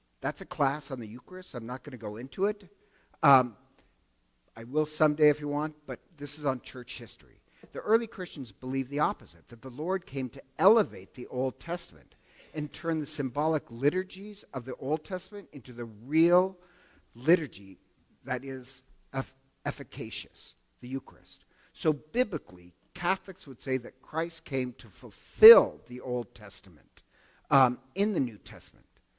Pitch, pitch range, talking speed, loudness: 135 Hz, 120-165 Hz, 160 wpm, -29 LUFS